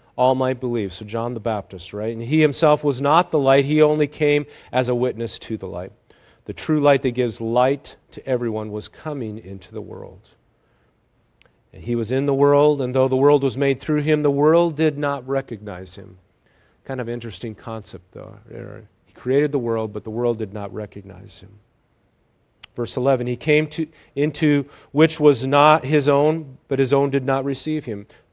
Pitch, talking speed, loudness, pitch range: 130 Hz, 195 wpm, -20 LUFS, 110-145 Hz